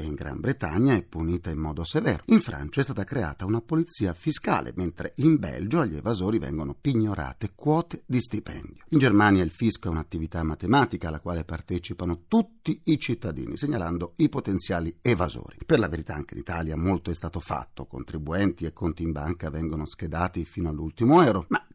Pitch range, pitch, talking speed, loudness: 80-120 Hz, 90 Hz, 175 wpm, -26 LUFS